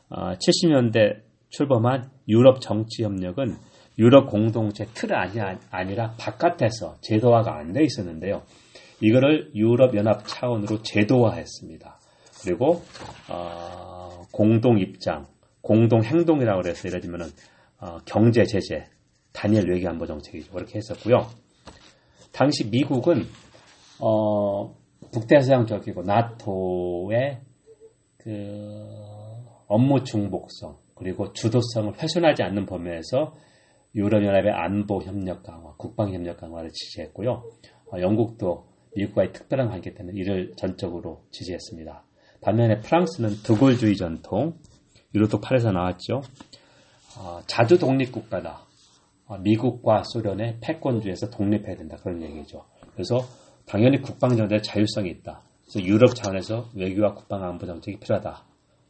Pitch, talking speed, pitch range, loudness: 105 Hz, 285 characters per minute, 95-120 Hz, -23 LUFS